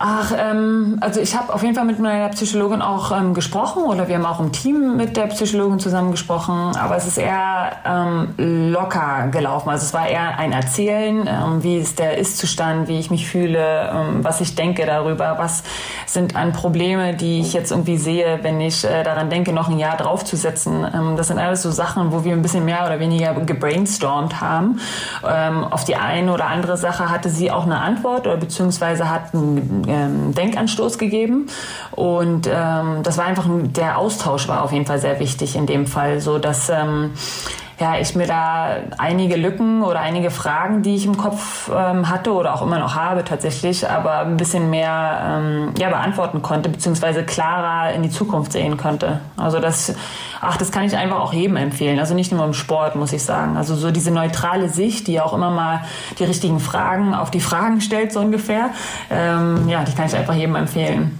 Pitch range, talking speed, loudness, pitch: 160-185 Hz, 200 wpm, -19 LUFS, 170 Hz